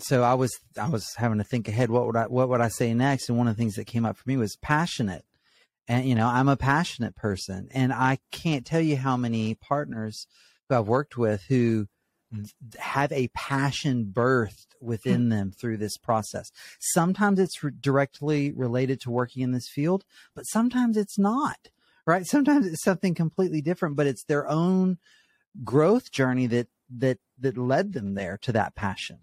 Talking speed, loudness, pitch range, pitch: 190 wpm, -26 LUFS, 115-150 Hz, 130 Hz